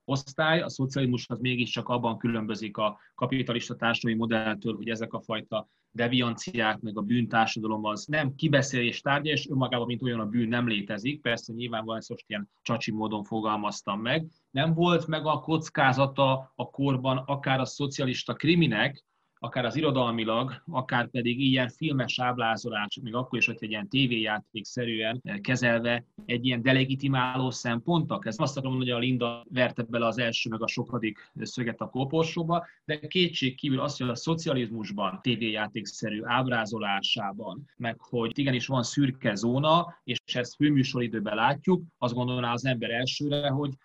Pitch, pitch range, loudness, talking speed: 125 Hz, 115-135 Hz, -28 LUFS, 150 wpm